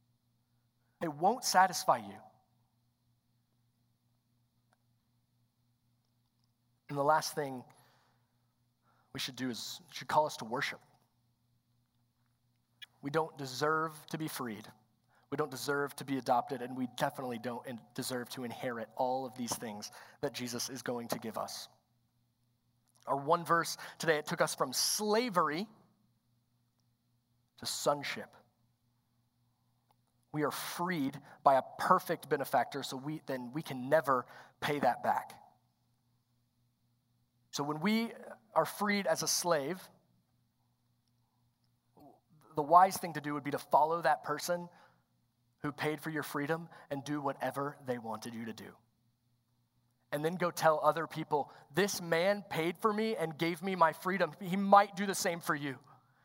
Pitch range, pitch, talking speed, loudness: 120-155 Hz, 130 Hz, 140 wpm, -34 LUFS